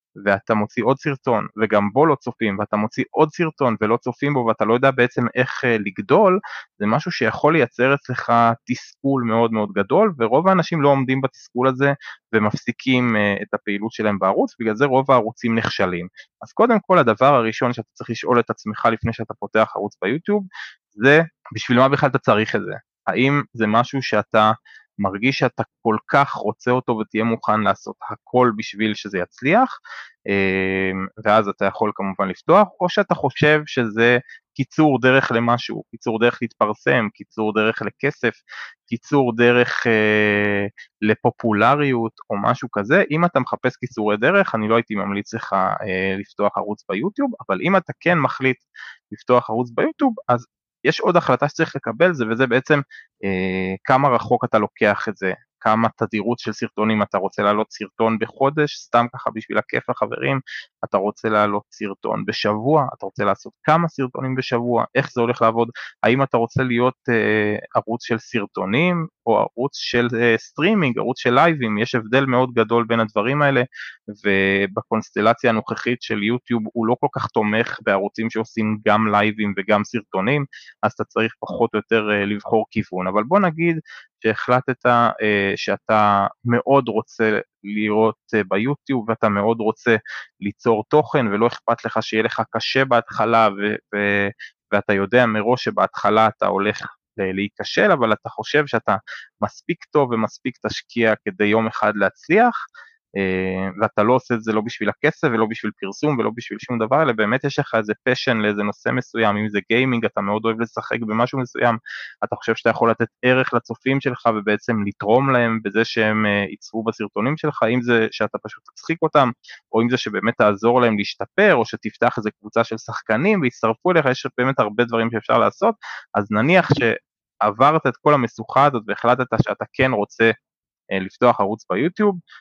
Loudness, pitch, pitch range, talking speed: -19 LUFS, 115 Hz, 105-130 Hz, 165 wpm